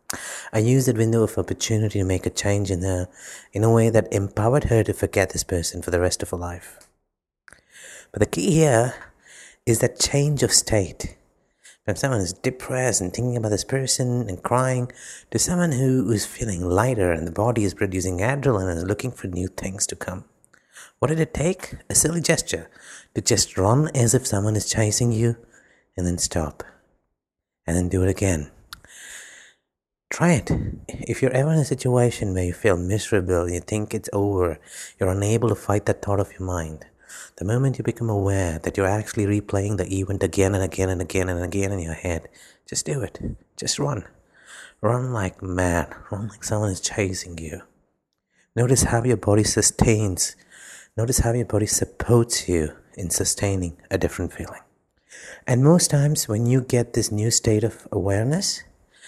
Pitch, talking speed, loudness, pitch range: 105 Hz, 180 wpm, -22 LUFS, 95-120 Hz